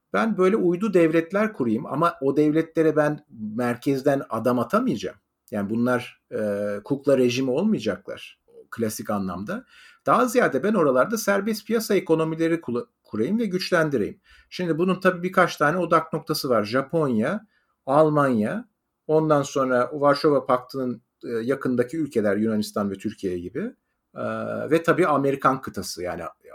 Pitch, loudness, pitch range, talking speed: 150 Hz, -23 LUFS, 125-180 Hz, 130 wpm